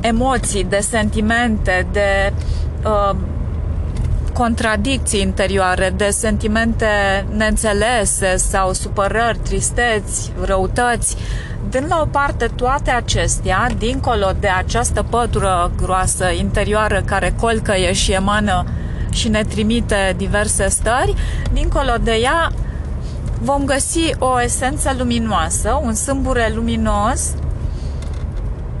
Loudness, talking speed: -17 LUFS, 95 wpm